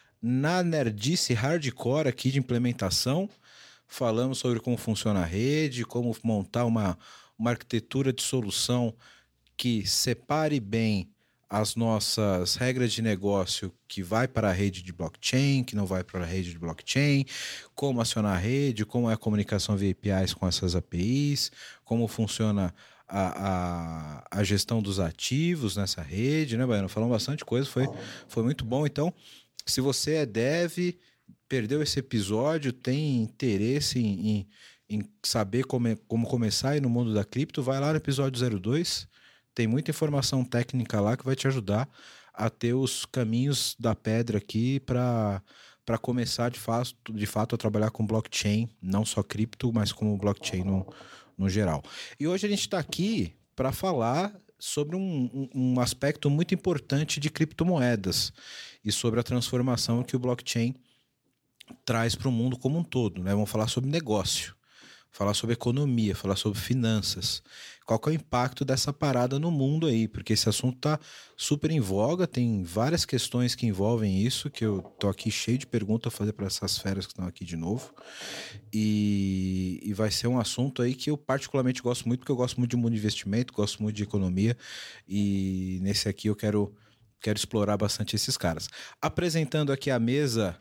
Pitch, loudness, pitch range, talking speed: 115 Hz, -28 LUFS, 105-130 Hz, 170 wpm